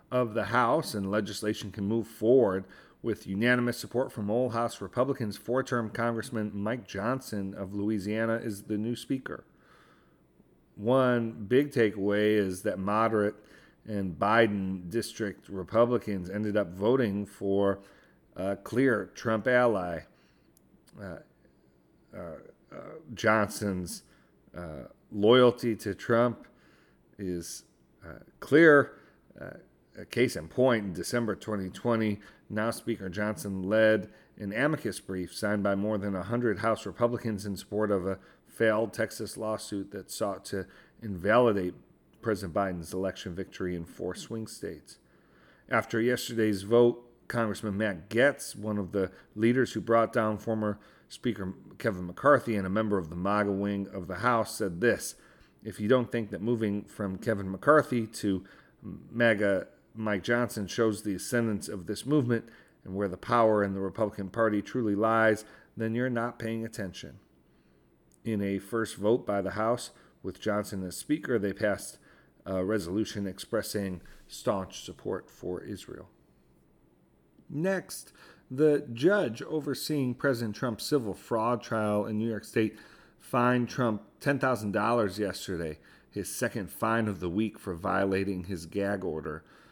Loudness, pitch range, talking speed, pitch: -29 LUFS, 100-115 Hz, 140 wpm, 105 Hz